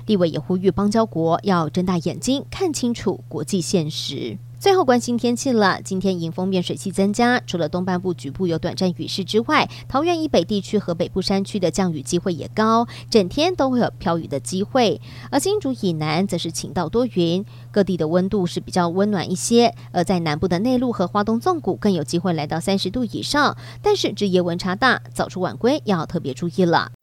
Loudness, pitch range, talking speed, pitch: -21 LUFS, 175-225 Hz, 315 characters per minute, 185 Hz